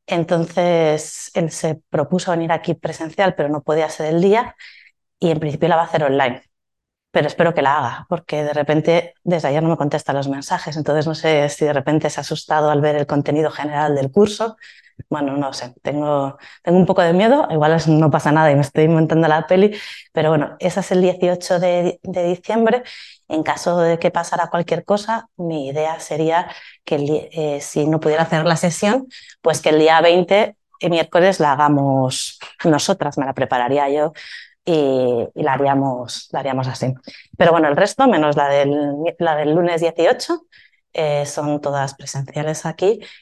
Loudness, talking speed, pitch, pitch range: -18 LUFS, 190 wpm, 160 Hz, 145-175 Hz